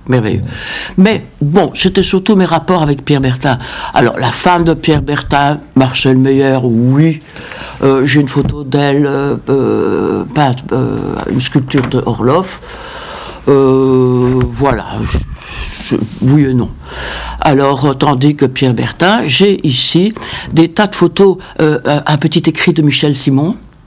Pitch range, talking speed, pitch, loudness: 130-160 Hz, 140 wpm, 145 Hz, -11 LUFS